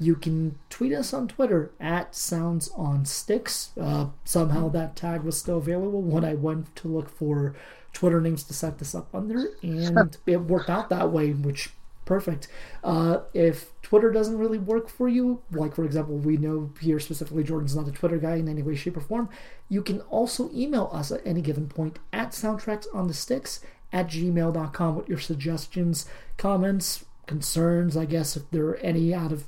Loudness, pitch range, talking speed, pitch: -27 LUFS, 155-190 Hz, 190 wpm, 165 Hz